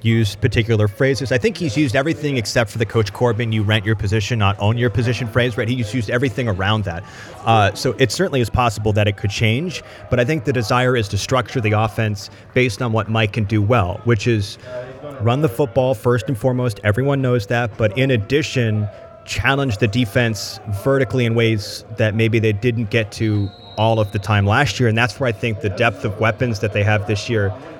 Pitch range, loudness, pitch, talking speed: 110-125 Hz, -18 LUFS, 115 Hz, 220 wpm